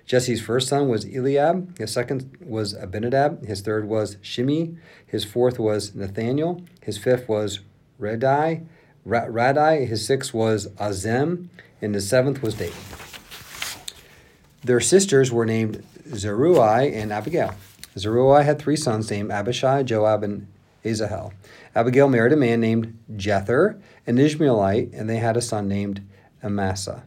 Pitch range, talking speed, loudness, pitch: 105-135 Hz, 135 wpm, -22 LUFS, 115 Hz